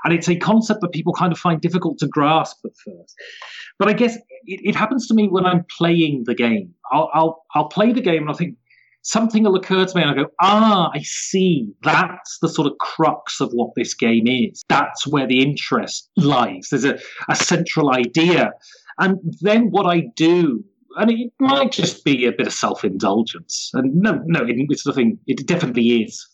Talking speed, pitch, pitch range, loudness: 205 wpm, 175 Hz, 150-210 Hz, -18 LUFS